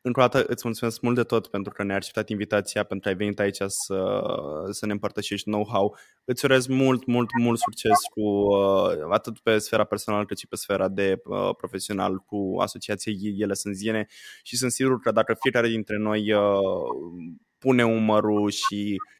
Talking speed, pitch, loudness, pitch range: 185 wpm, 105 Hz, -25 LUFS, 100-115 Hz